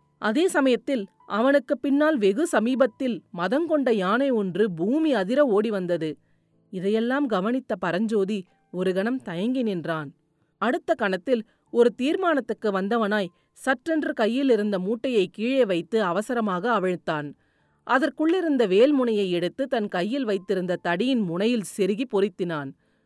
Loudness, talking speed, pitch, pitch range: -24 LUFS, 110 wpm, 220 Hz, 190-265 Hz